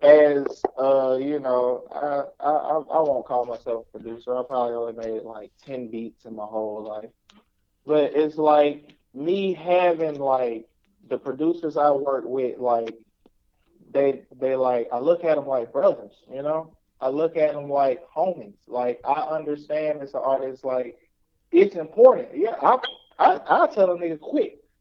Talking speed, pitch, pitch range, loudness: 165 wpm, 140 Hz, 125-155 Hz, -23 LUFS